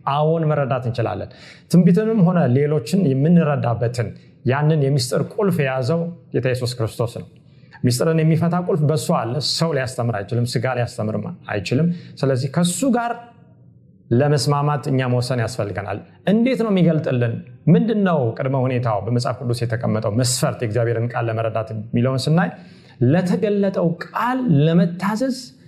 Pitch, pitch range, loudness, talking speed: 140 Hz, 120-170 Hz, -20 LUFS, 120 wpm